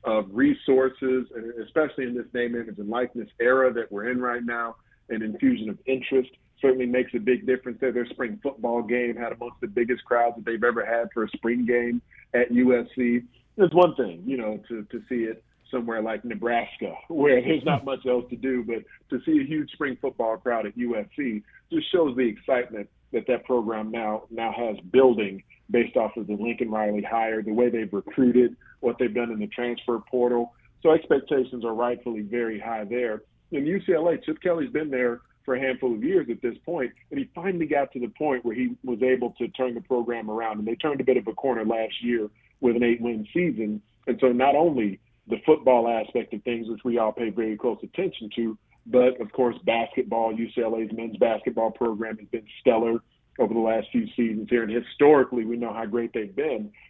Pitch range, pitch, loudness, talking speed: 115-130 Hz, 120 Hz, -25 LUFS, 210 wpm